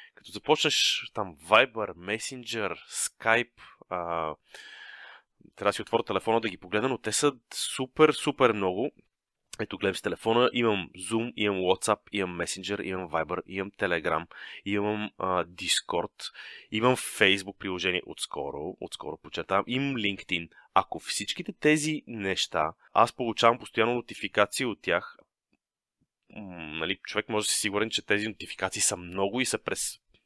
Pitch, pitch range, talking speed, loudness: 105 Hz, 95-115 Hz, 140 wpm, -28 LUFS